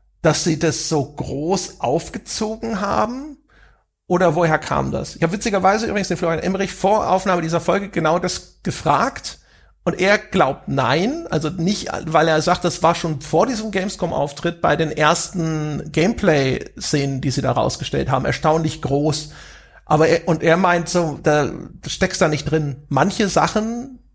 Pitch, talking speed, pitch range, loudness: 170 Hz, 160 wpm, 155-190 Hz, -19 LUFS